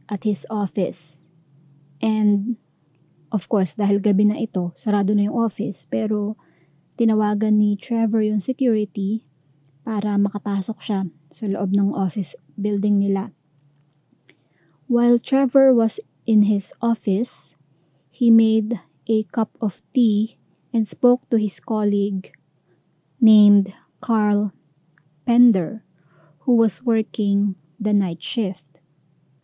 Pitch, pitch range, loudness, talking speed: 205 Hz, 165-220 Hz, -21 LUFS, 110 wpm